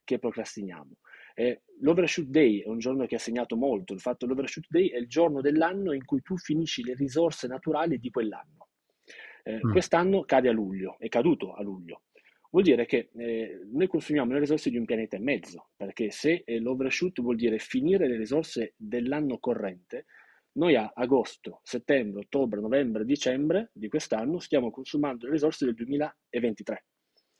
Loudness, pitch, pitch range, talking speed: -28 LUFS, 135 Hz, 115-160 Hz, 165 wpm